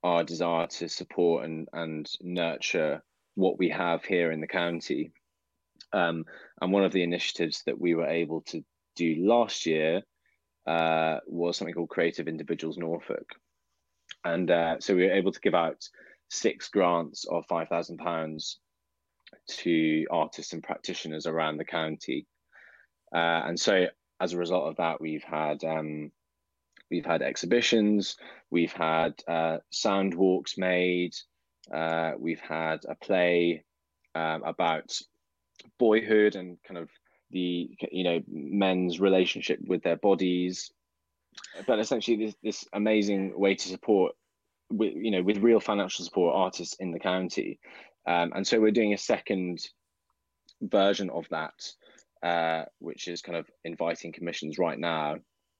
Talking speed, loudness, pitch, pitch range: 140 wpm, -29 LUFS, 85 Hz, 80-90 Hz